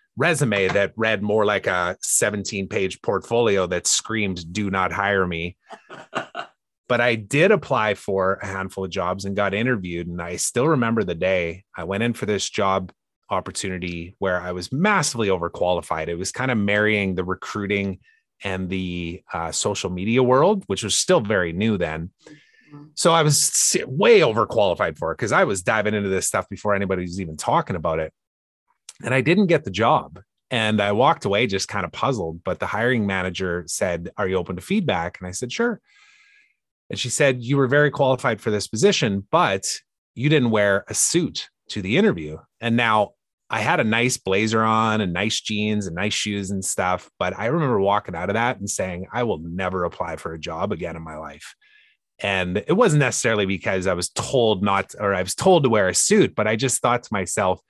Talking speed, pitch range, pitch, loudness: 200 wpm, 95-120 Hz, 100 Hz, -21 LUFS